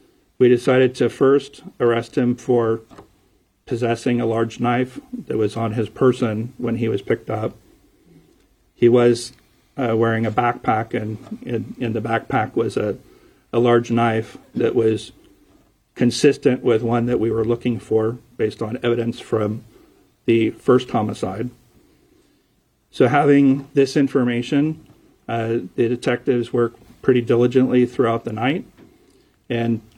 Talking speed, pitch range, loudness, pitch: 135 wpm, 115-125 Hz, -20 LUFS, 120 Hz